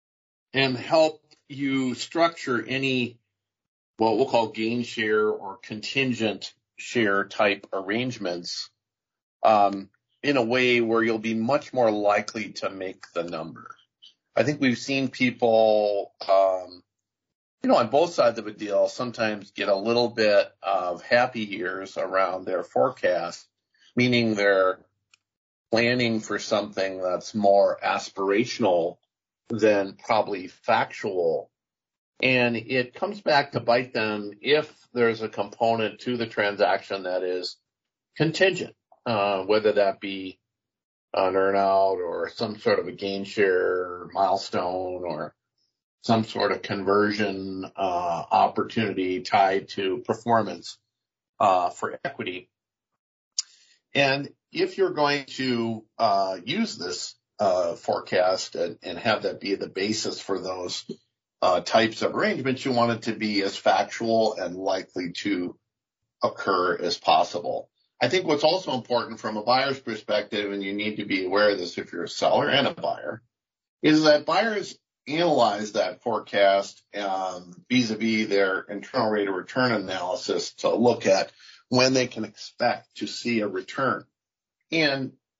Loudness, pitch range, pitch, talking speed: -25 LUFS, 100-125 Hz, 110 Hz, 135 wpm